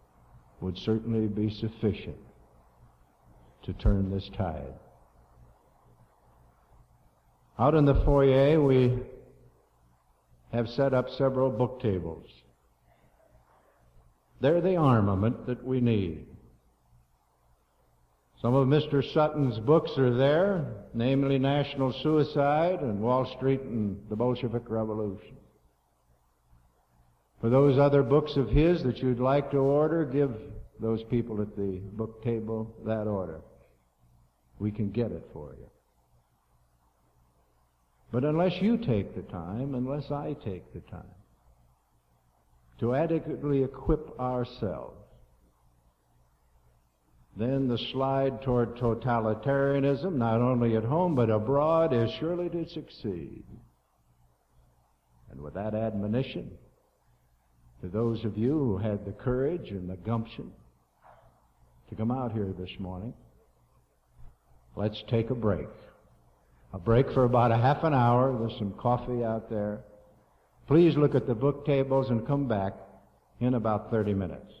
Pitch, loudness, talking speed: 110 Hz, -28 LUFS, 120 wpm